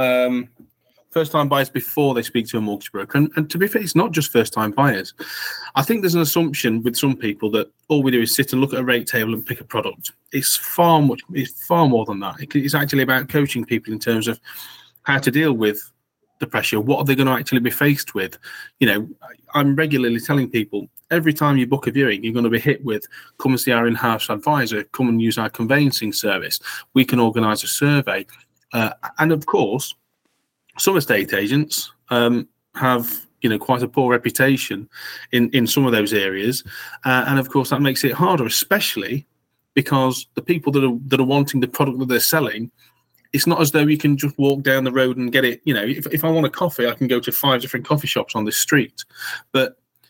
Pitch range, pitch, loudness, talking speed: 120-145 Hz, 130 Hz, -19 LUFS, 225 wpm